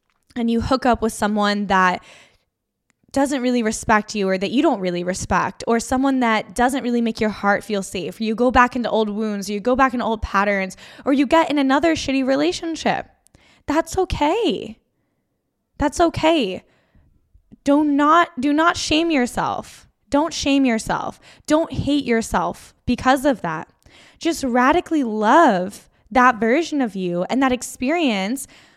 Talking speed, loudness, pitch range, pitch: 160 wpm, -19 LUFS, 215-285 Hz, 250 Hz